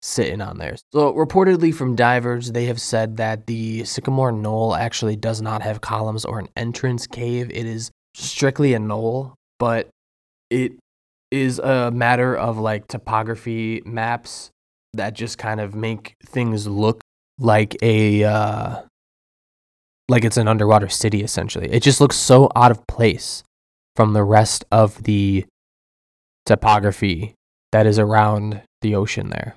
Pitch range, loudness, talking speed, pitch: 105-120 Hz, -19 LUFS, 145 wpm, 110 Hz